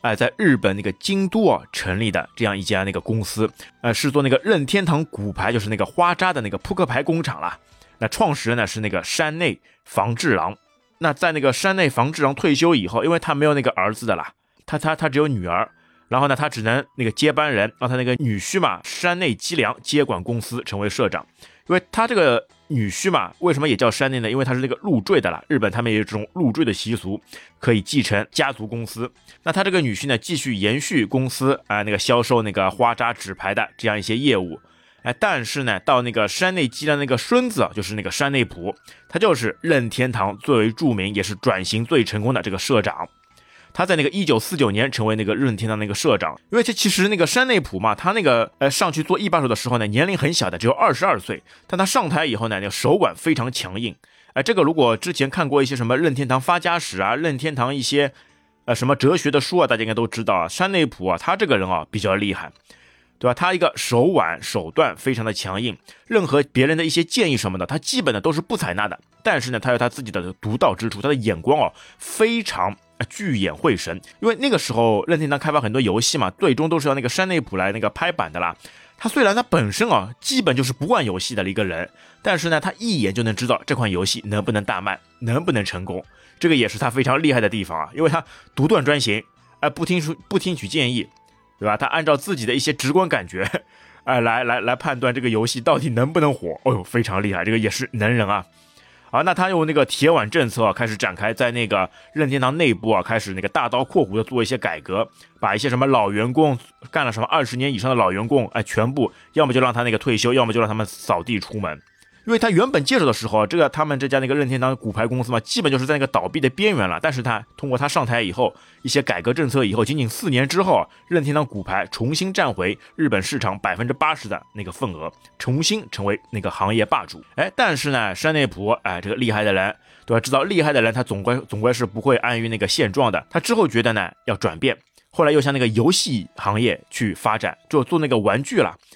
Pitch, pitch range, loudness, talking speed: 125 Hz, 110-150 Hz, -20 LUFS, 355 characters per minute